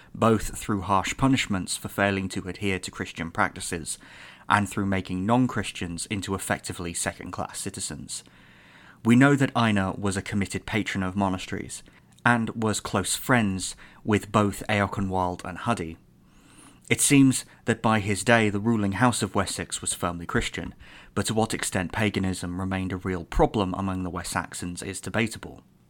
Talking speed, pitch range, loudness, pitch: 155 wpm, 95-110 Hz, -26 LUFS, 100 Hz